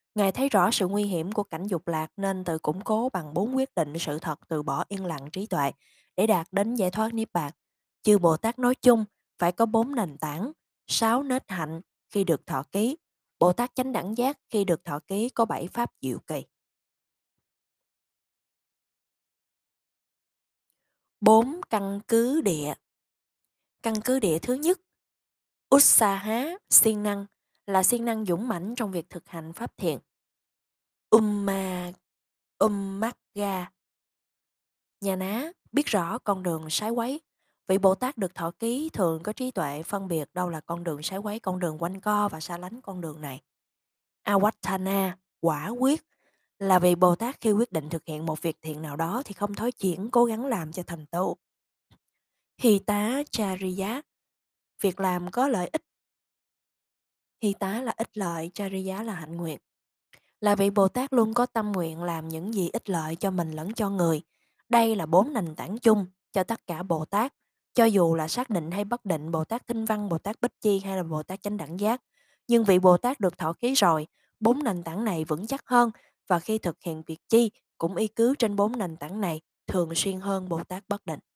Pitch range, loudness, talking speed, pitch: 170-225 Hz, -27 LUFS, 190 wpm, 195 Hz